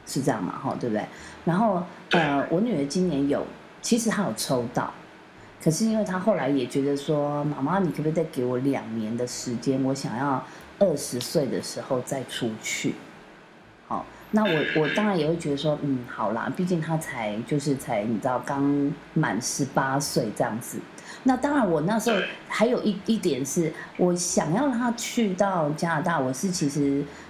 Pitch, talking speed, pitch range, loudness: 160 Hz, 260 characters per minute, 140-205 Hz, -26 LUFS